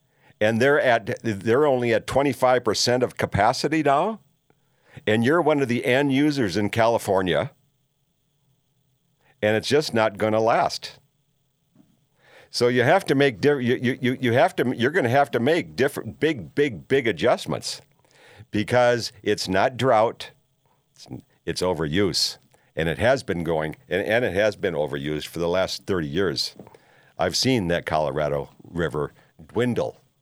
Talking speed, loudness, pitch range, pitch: 155 wpm, -22 LUFS, 110-145 Hz, 130 Hz